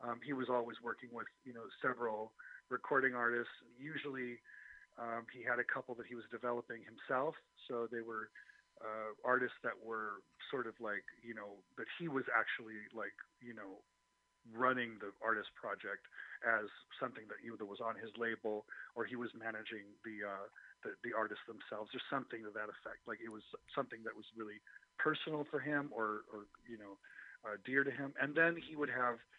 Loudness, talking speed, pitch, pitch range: -42 LUFS, 185 wpm, 120 Hz, 110-130 Hz